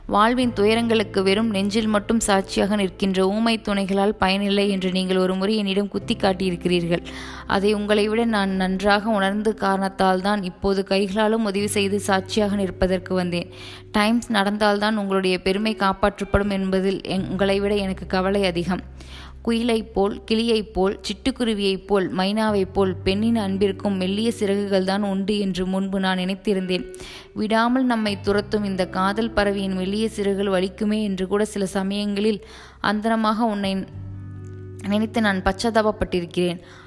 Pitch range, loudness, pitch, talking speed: 190-210 Hz, -22 LUFS, 200 Hz, 130 wpm